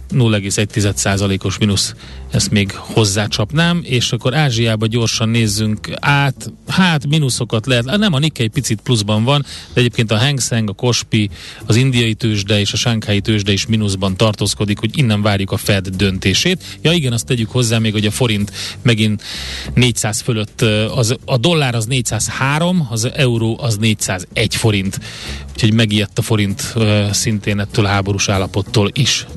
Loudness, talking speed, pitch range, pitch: -15 LUFS, 155 wpm, 105-125 Hz, 110 Hz